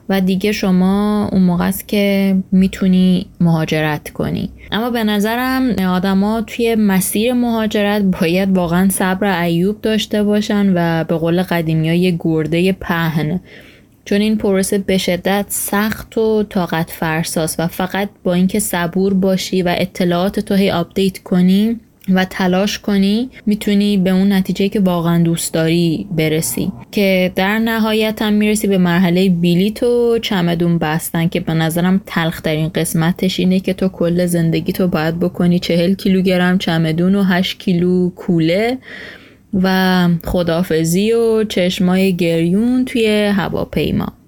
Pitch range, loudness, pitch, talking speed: 175-205 Hz, -15 LUFS, 190 Hz, 140 wpm